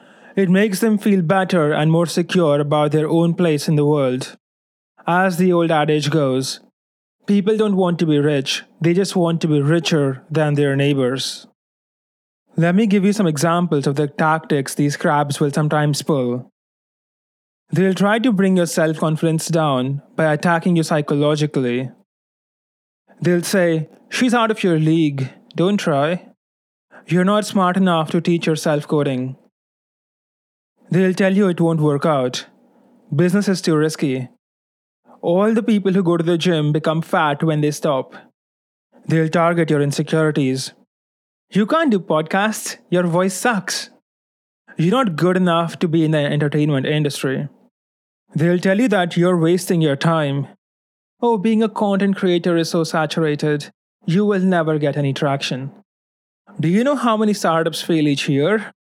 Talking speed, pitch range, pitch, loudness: 155 wpm, 150-185 Hz, 165 Hz, -18 LUFS